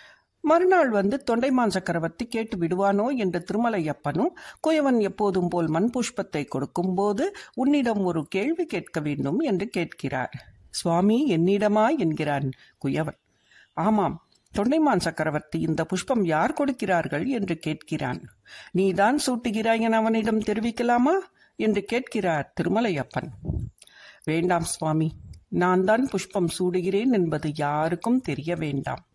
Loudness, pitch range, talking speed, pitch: -25 LUFS, 165-235 Hz, 110 wpm, 195 Hz